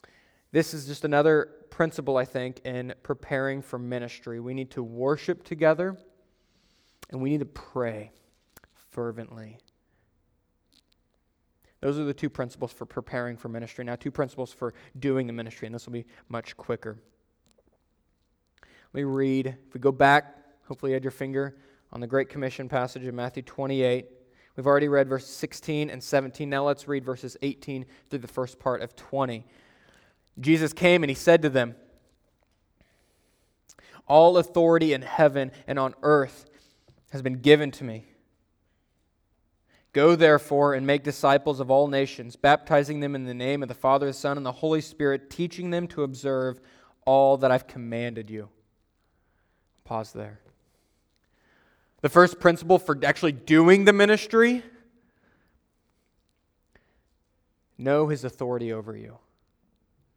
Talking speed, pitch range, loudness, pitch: 145 wpm, 120-145 Hz, -25 LUFS, 130 Hz